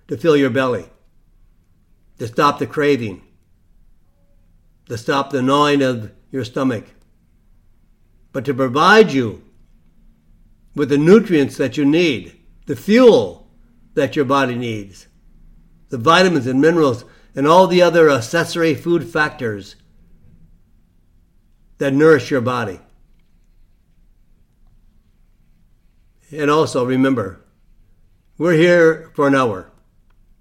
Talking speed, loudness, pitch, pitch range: 105 wpm, -16 LUFS, 120 Hz, 90-145 Hz